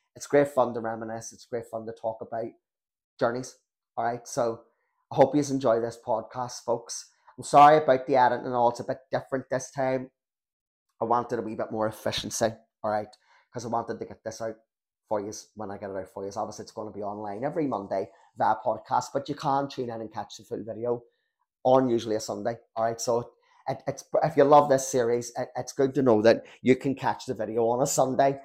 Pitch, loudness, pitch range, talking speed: 120 Hz, -27 LUFS, 110-135 Hz, 230 wpm